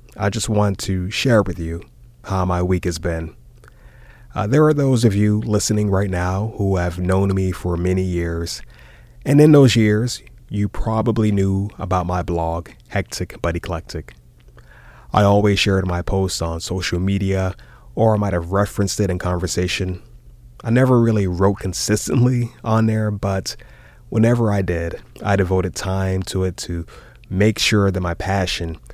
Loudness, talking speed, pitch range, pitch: -19 LUFS, 165 wpm, 90-110 Hz, 95 Hz